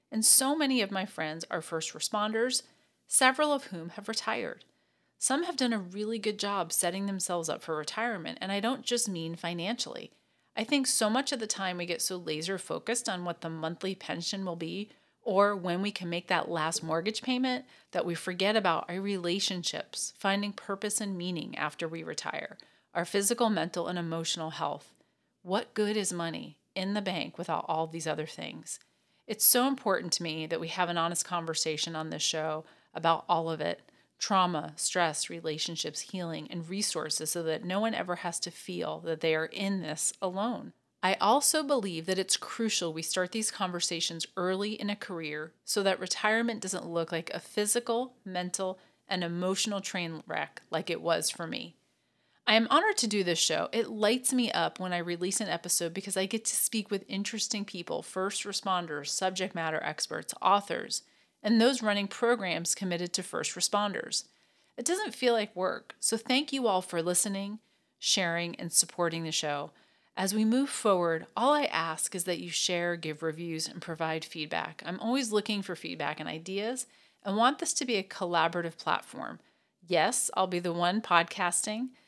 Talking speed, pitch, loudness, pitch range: 185 wpm, 185 Hz, -30 LUFS, 170-215 Hz